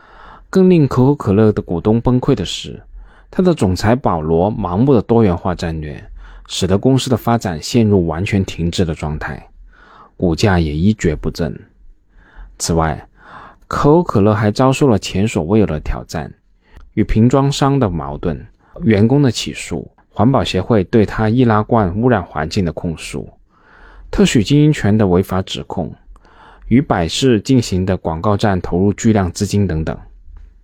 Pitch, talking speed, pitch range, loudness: 105 Hz, 240 characters per minute, 85-120 Hz, -15 LUFS